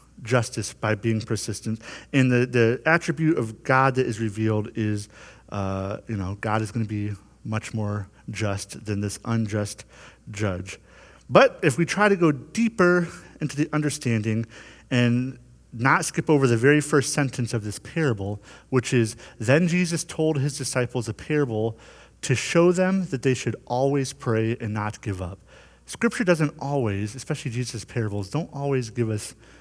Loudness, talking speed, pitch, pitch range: -24 LUFS, 165 wpm, 120 Hz, 110-145 Hz